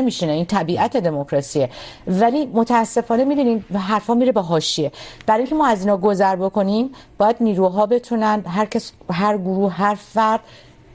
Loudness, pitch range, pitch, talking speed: -19 LUFS, 190-230 Hz, 210 Hz, 150 wpm